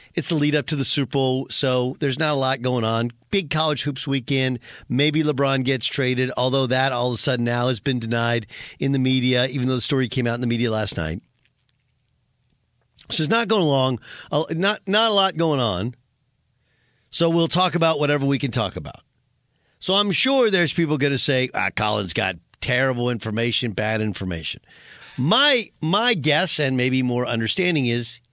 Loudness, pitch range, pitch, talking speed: -21 LUFS, 120-150 Hz, 130 Hz, 190 wpm